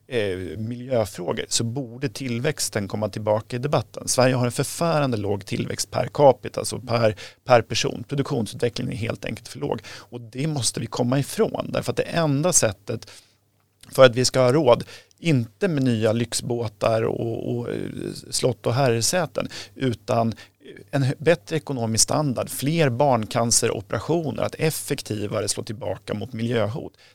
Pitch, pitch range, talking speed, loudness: 120 Hz, 110-140 Hz, 145 wpm, -23 LUFS